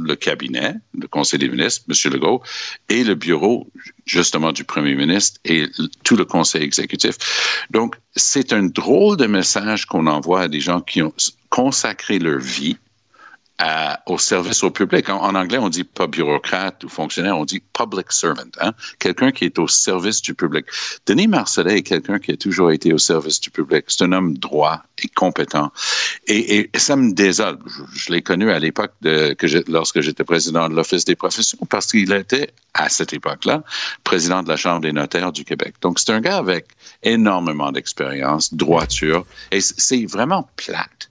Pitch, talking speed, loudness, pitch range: 85 Hz, 185 wpm, -18 LUFS, 80-100 Hz